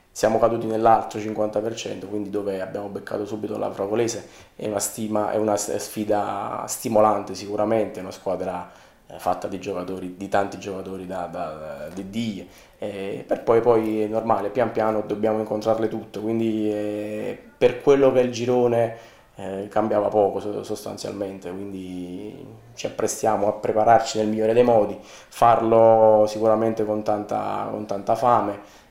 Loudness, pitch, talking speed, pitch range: -23 LUFS, 105 Hz, 140 wpm, 100-110 Hz